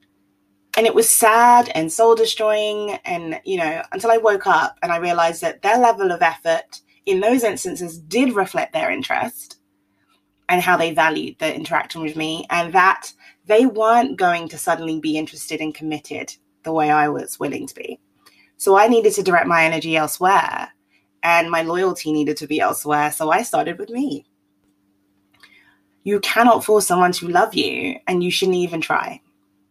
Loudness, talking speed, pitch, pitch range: -18 LUFS, 175 wpm, 170 Hz, 150-220 Hz